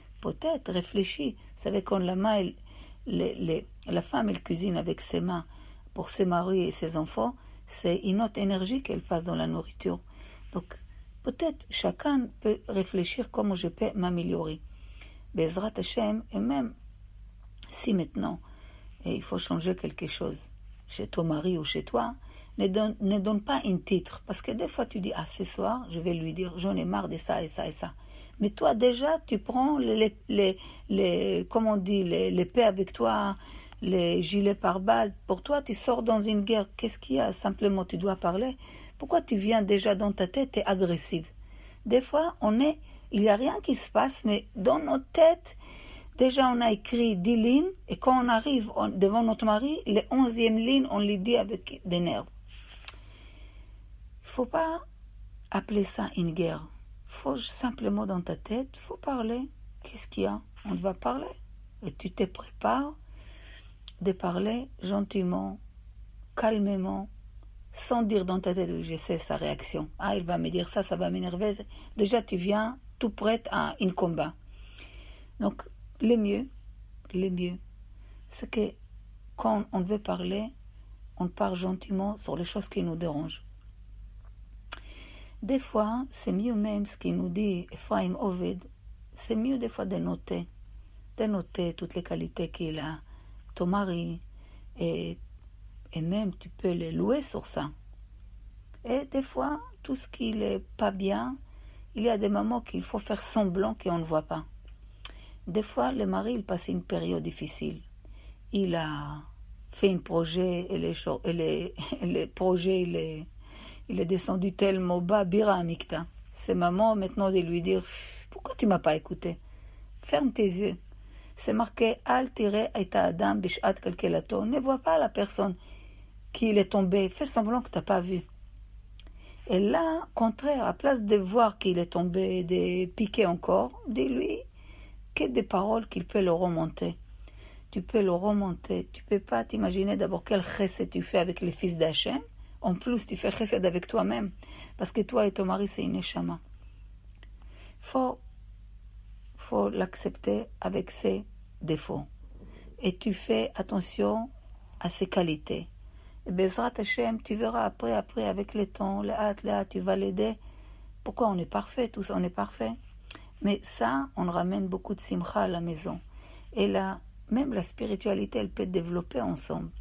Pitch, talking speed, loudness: 185 Hz, 165 wpm, -30 LUFS